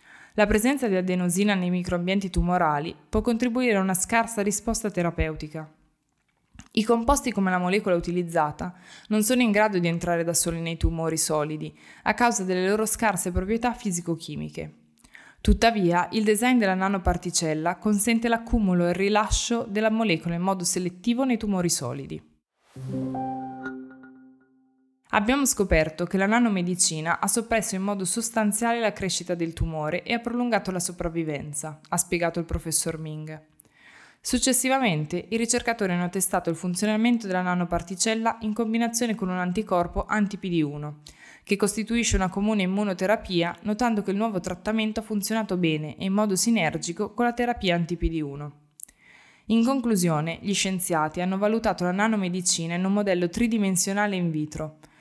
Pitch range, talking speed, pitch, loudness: 170-220 Hz, 140 wpm, 185 Hz, -25 LUFS